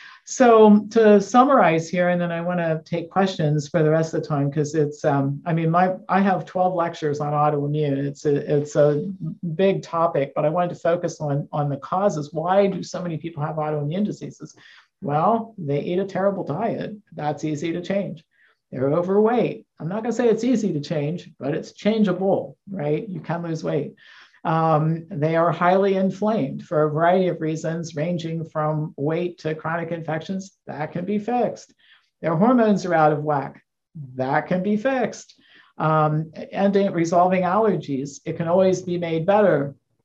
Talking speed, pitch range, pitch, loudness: 180 wpm, 150-190 Hz, 170 Hz, -22 LUFS